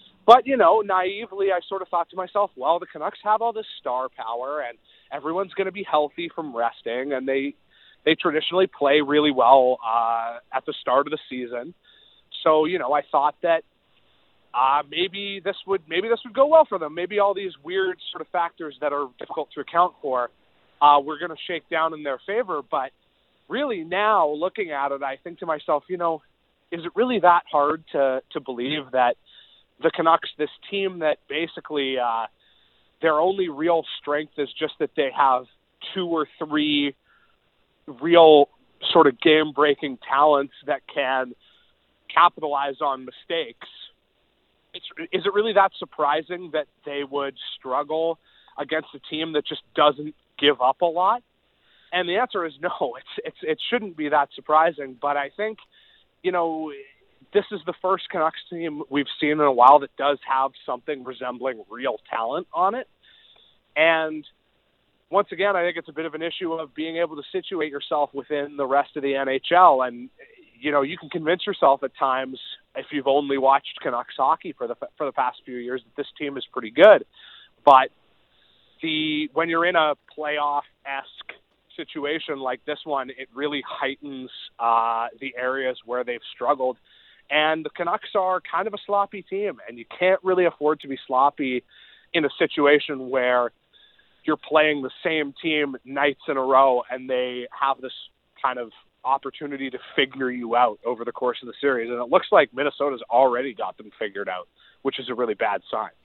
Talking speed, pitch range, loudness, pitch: 180 wpm, 135-175 Hz, -23 LUFS, 150 Hz